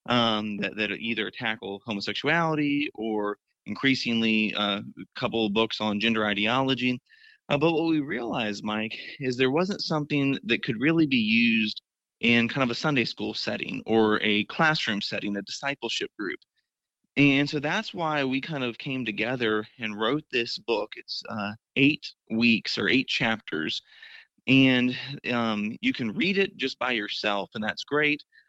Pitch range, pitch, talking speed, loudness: 110-150 Hz, 125 Hz, 160 wpm, -26 LUFS